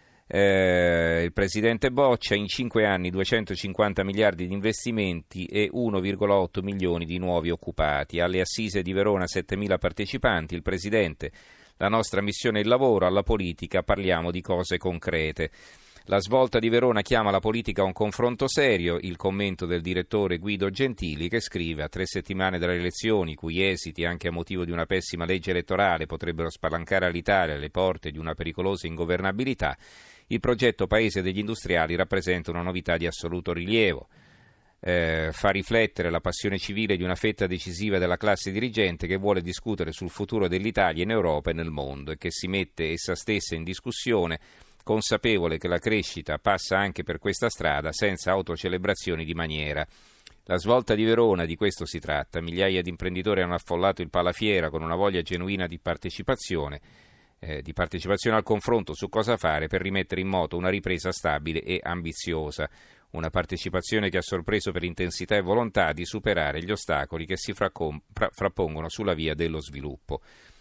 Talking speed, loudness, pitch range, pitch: 165 wpm, -26 LUFS, 85-105 Hz, 95 Hz